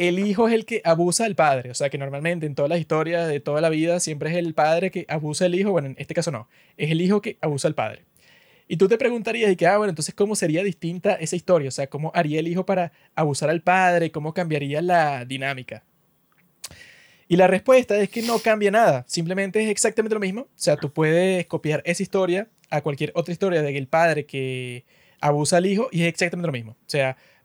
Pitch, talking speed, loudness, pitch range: 170 Hz, 235 wpm, -22 LUFS, 150-190 Hz